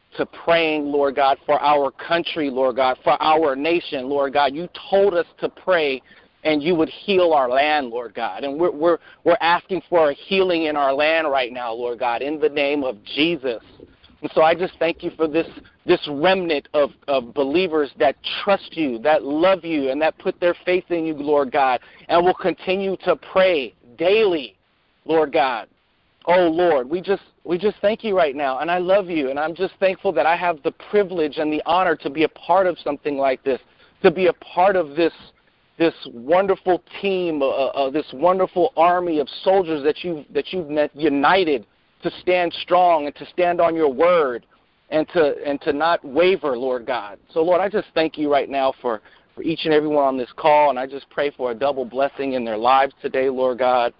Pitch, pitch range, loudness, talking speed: 160 Hz, 145-180 Hz, -20 LUFS, 210 wpm